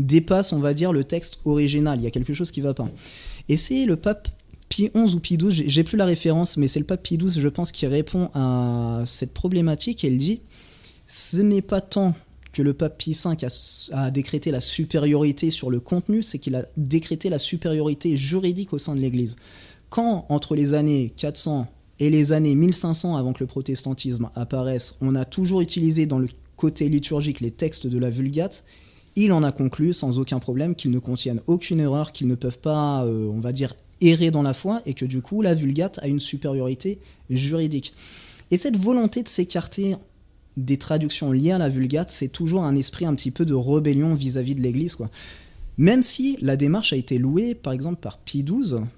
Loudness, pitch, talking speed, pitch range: -23 LUFS, 150 Hz, 210 wpm, 130-175 Hz